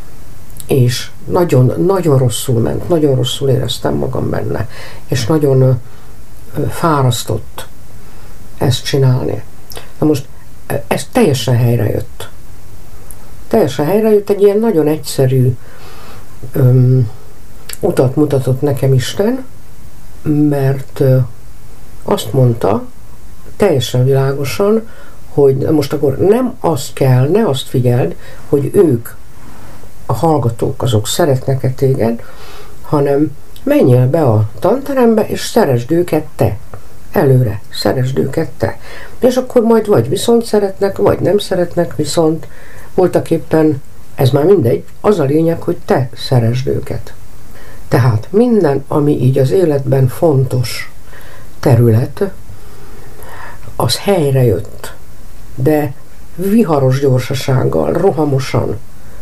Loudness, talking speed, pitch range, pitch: -13 LUFS, 105 wpm, 115-150 Hz, 130 Hz